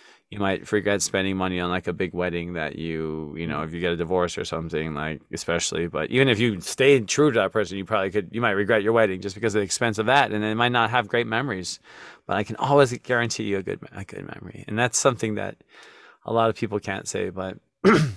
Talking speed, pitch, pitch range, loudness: 250 wpm, 100 Hz, 90-115 Hz, -24 LUFS